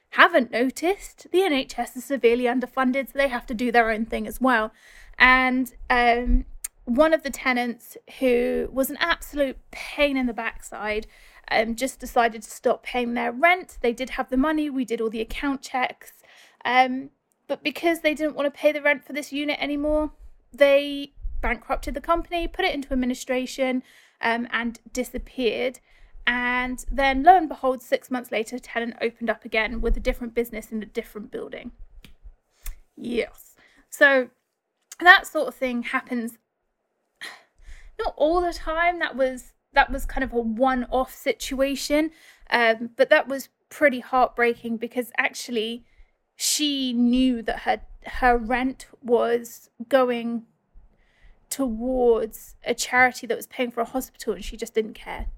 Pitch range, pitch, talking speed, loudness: 235-280 Hz, 255 Hz, 160 wpm, -23 LUFS